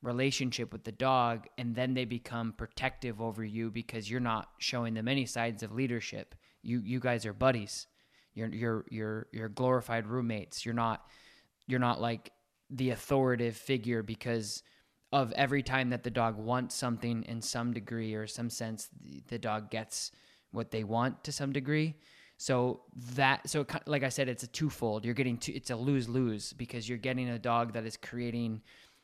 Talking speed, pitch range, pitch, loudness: 185 wpm, 115-130 Hz, 120 Hz, -34 LUFS